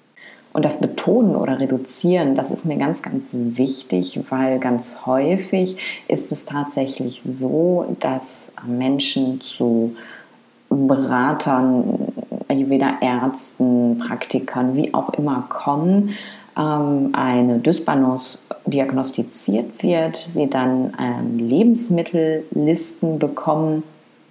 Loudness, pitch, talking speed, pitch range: -20 LUFS, 135 Hz, 95 wpm, 130-155 Hz